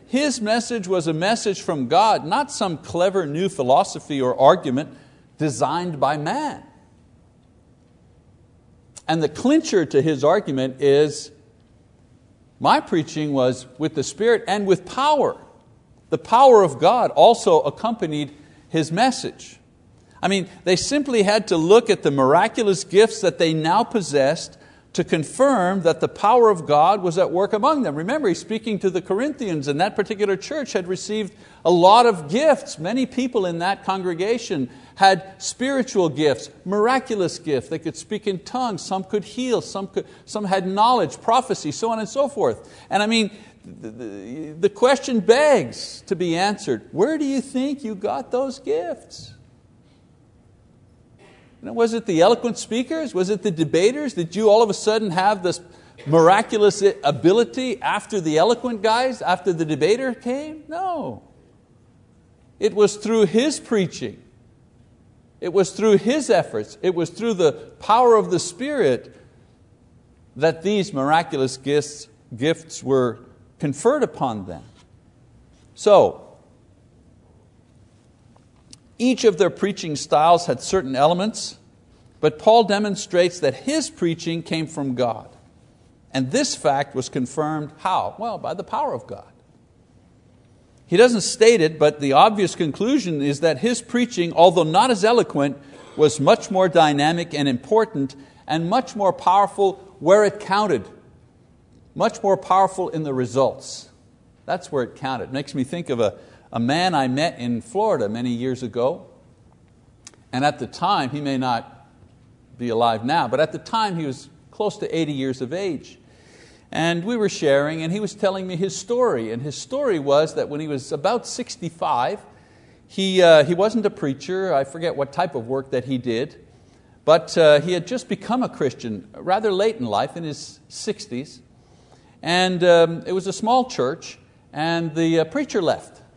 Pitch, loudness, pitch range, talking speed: 180 Hz, -20 LUFS, 145-215 Hz, 160 wpm